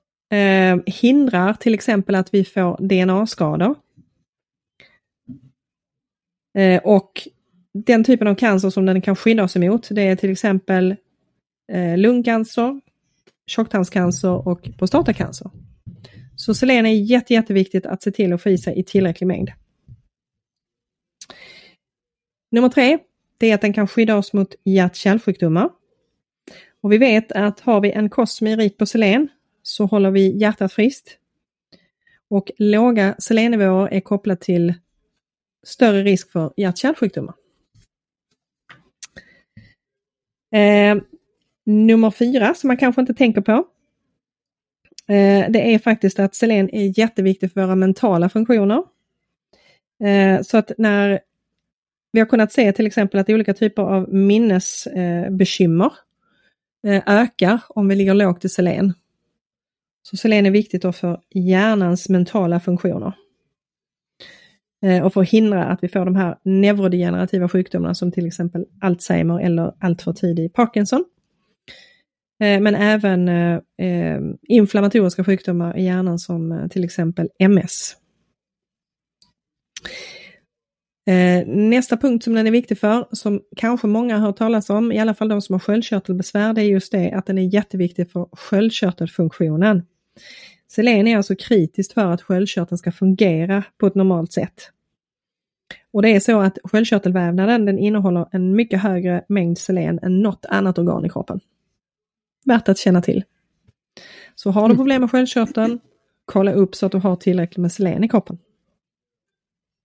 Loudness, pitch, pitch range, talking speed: -17 LUFS, 200 Hz, 185-220 Hz, 140 wpm